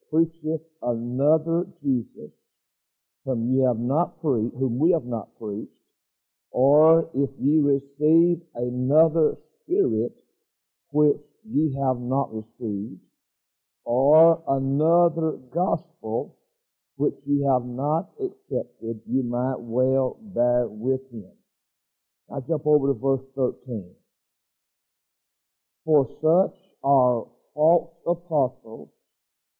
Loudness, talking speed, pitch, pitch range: -24 LUFS, 100 wpm, 140 Hz, 125-160 Hz